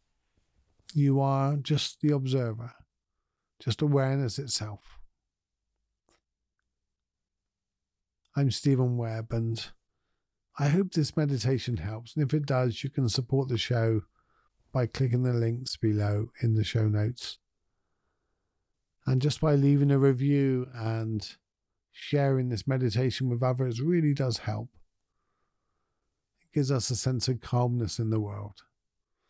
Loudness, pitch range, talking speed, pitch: -28 LUFS, 110-135 Hz, 125 wpm, 125 Hz